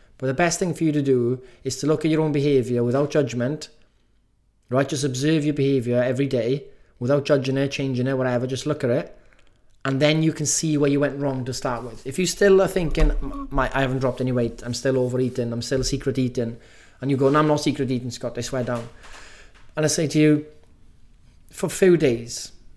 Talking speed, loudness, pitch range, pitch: 220 wpm, -22 LUFS, 125-150 Hz, 135 Hz